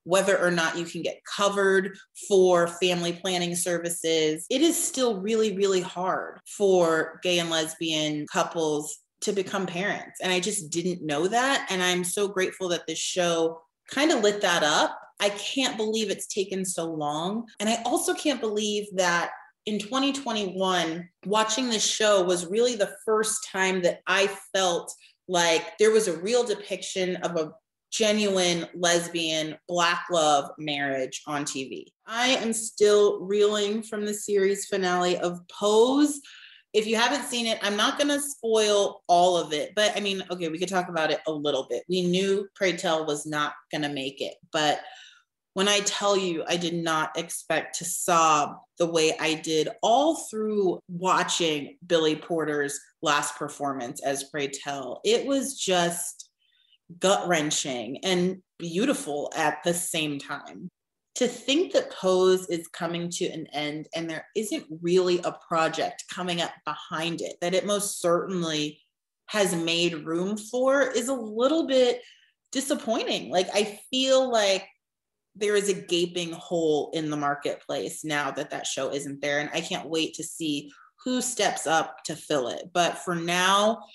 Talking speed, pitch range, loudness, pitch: 165 wpm, 165-210 Hz, -26 LUFS, 180 Hz